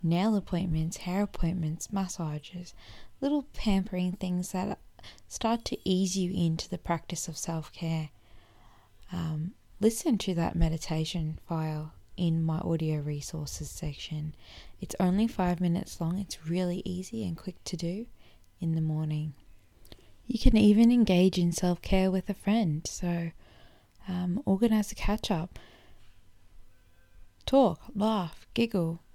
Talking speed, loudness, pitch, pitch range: 130 wpm, -30 LUFS, 175 Hz, 155-190 Hz